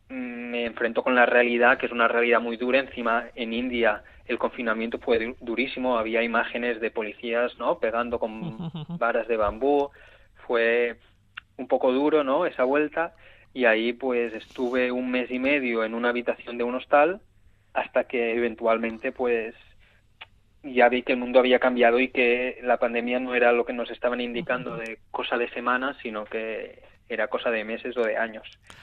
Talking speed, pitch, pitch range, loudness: 175 wpm, 120 Hz, 115-125 Hz, -25 LUFS